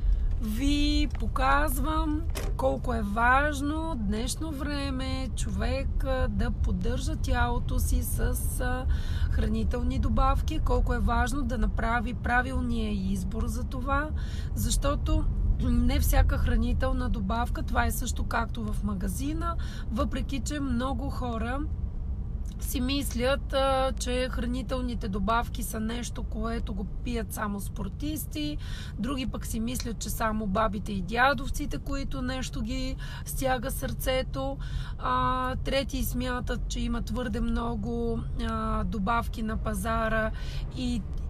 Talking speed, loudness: 110 wpm, -30 LUFS